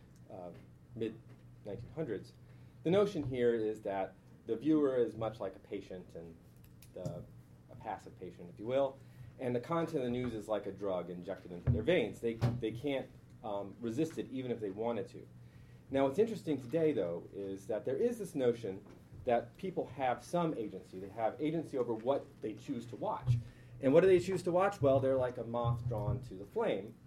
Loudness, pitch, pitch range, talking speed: -36 LUFS, 120 Hz, 105-140 Hz, 195 wpm